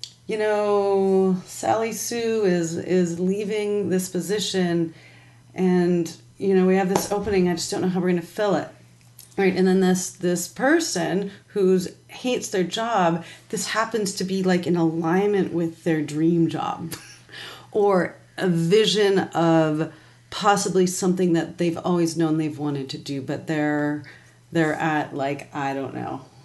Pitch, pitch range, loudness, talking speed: 180 Hz, 160-195 Hz, -23 LUFS, 155 wpm